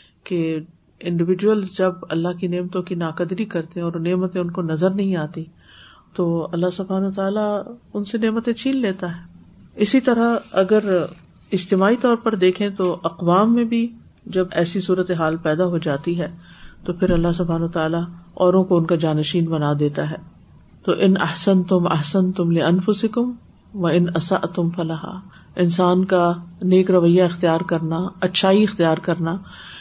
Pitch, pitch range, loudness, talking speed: 180 Hz, 170-195 Hz, -20 LUFS, 160 wpm